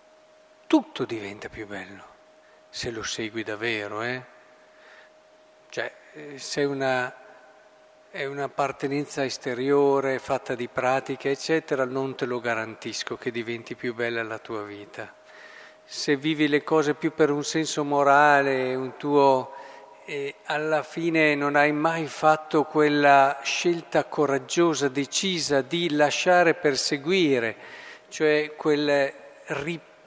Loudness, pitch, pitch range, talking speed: -24 LUFS, 145 Hz, 130-155 Hz, 120 wpm